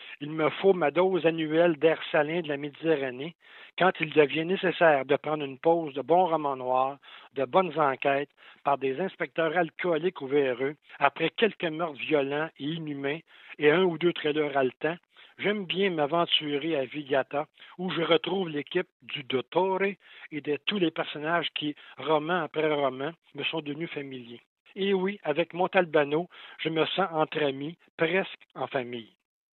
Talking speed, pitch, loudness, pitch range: 165 wpm, 155 Hz, -28 LUFS, 145-170 Hz